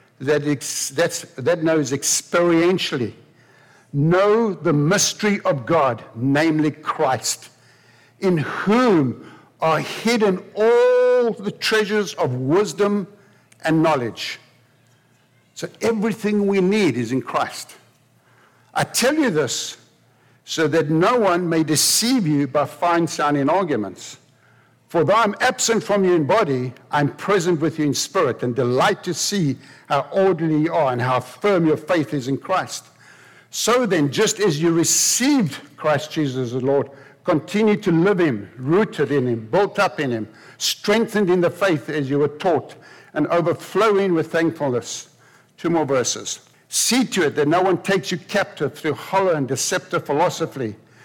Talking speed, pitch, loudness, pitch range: 145 wpm, 160 Hz, -20 LUFS, 140-195 Hz